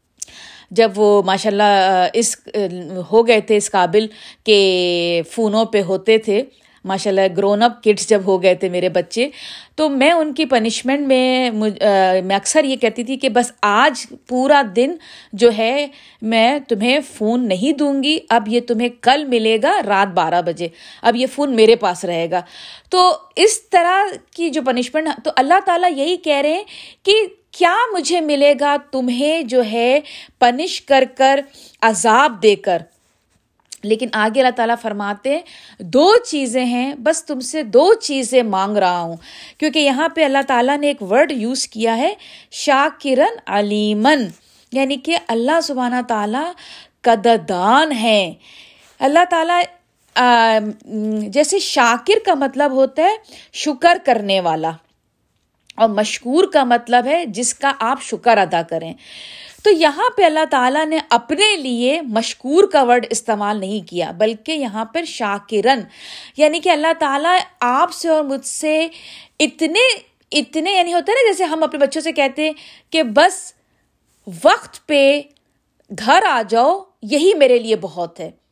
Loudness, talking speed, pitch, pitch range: -16 LUFS, 155 wpm, 260 Hz, 220-310 Hz